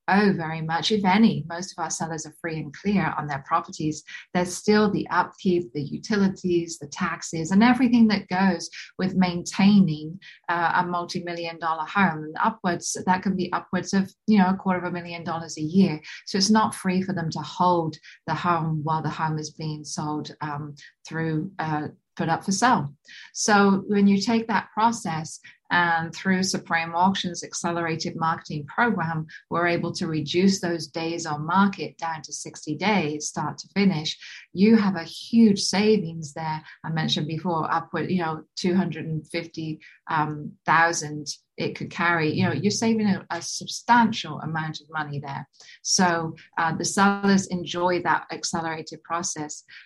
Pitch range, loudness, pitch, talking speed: 160-190 Hz, -24 LUFS, 170 Hz, 165 wpm